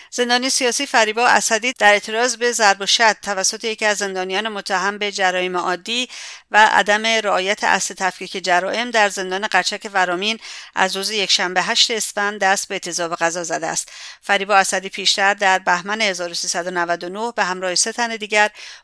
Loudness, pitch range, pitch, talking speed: -18 LUFS, 185-220 Hz, 200 Hz, 160 wpm